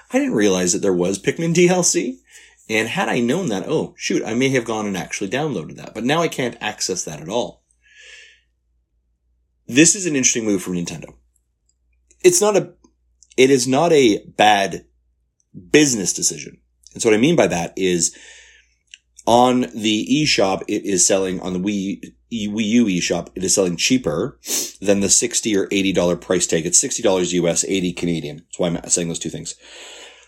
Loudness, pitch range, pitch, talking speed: -18 LUFS, 80-130 Hz, 95 Hz, 180 wpm